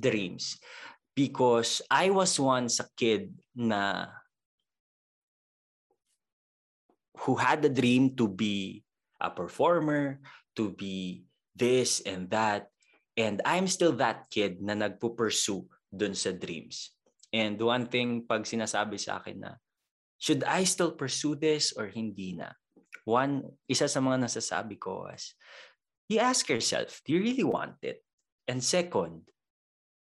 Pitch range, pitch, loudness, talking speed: 105-145 Hz, 120 Hz, -29 LUFS, 125 wpm